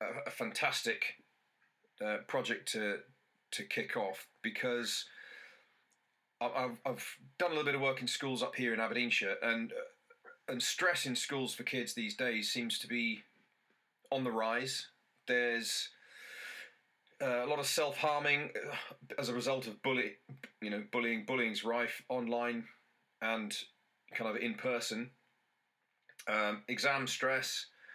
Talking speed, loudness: 135 wpm, -36 LUFS